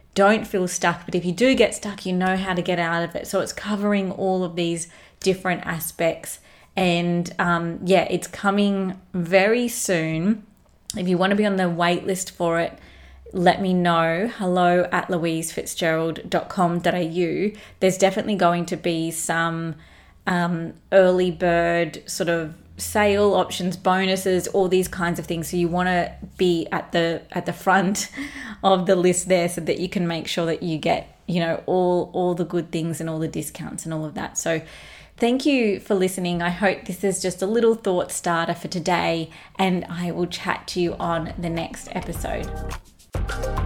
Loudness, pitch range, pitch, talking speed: -22 LUFS, 170-190 Hz, 180 Hz, 180 wpm